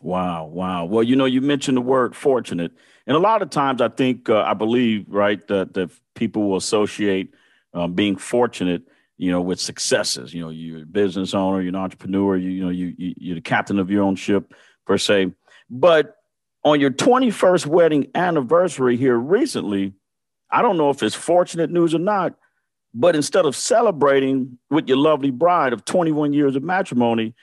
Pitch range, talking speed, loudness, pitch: 95-145 Hz, 190 wpm, -19 LUFS, 115 Hz